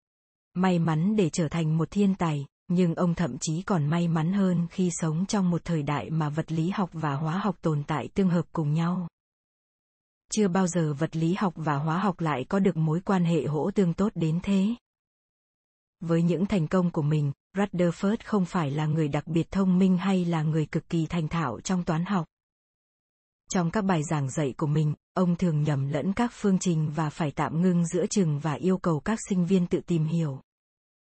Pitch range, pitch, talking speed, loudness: 155-185 Hz, 170 Hz, 210 wpm, -27 LUFS